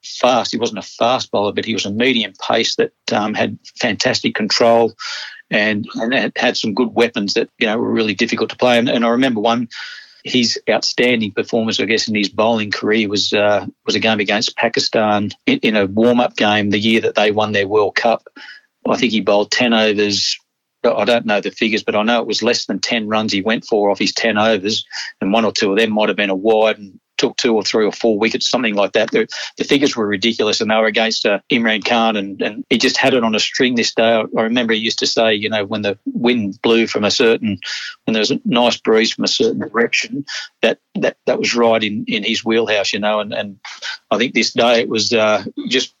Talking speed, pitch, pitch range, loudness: 240 wpm, 110 Hz, 105-115 Hz, -16 LUFS